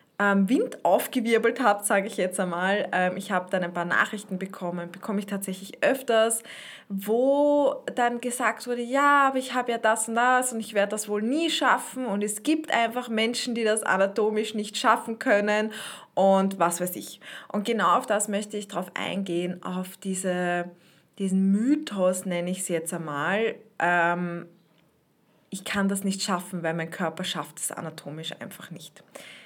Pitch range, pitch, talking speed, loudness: 180-225 Hz, 200 Hz, 165 wpm, -26 LUFS